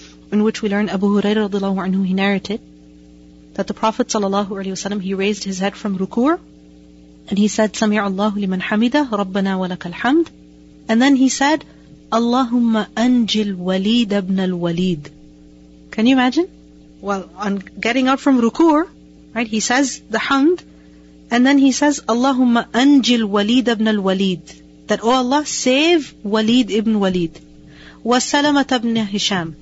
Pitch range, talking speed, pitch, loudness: 190-245 Hz, 150 wpm, 210 Hz, -17 LUFS